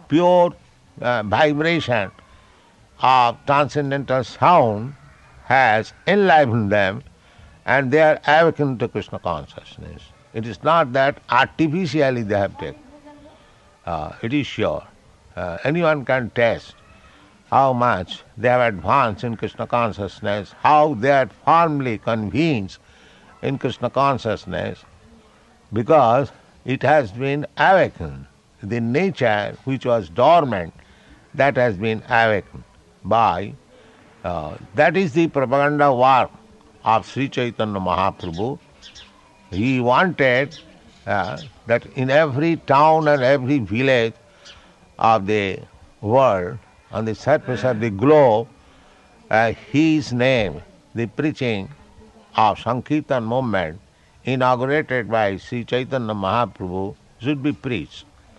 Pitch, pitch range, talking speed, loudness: 120 Hz, 105-140 Hz, 110 wpm, -19 LUFS